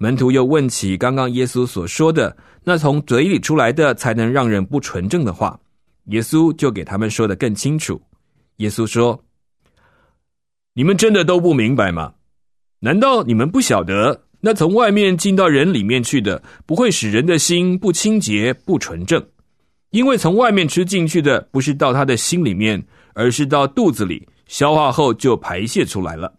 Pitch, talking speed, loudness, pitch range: 140 Hz, 255 characters per minute, -16 LUFS, 115-175 Hz